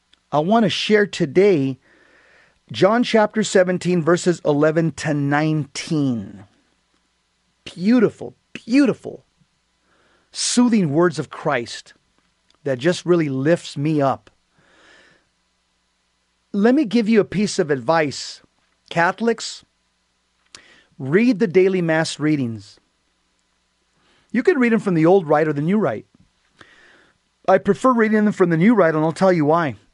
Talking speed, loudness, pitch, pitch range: 125 wpm, -18 LUFS, 170 Hz, 145-200 Hz